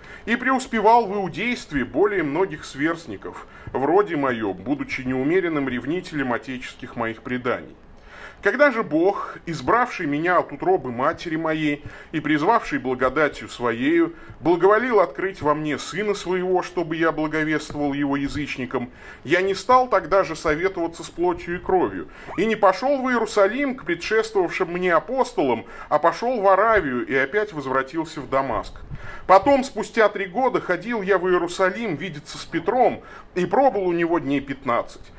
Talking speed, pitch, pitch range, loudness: 145 wpm, 180 Hz, 150-230 Hz, -22 LUFS